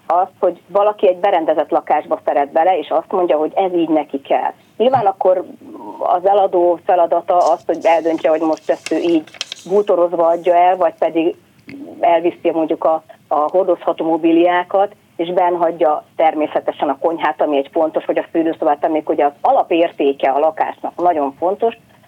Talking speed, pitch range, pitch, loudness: 160 wpm, 160-185 Hz, 170 Hz, -16 LUFS